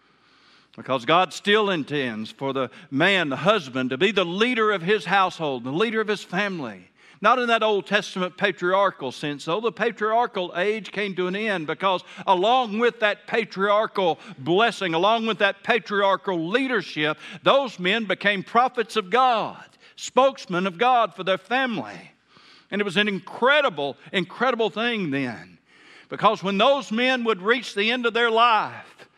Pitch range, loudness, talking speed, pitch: 180-225 Hz, -22 LUFS, 160 wpm, 200 Hz